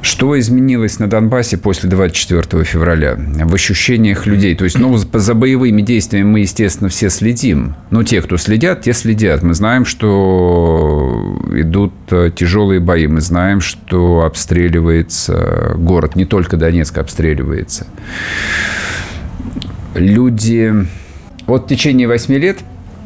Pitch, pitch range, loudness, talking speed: 95 Hz, 85-110 Hz, -12 LUFS, 120 wpm